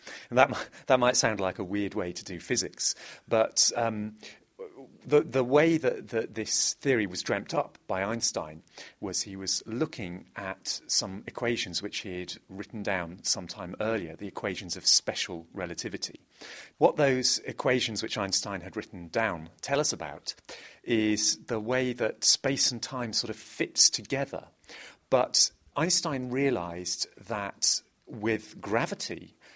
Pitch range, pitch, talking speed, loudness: 100-130 Hz, 110 Hz, 150 wpm, -28 LUFS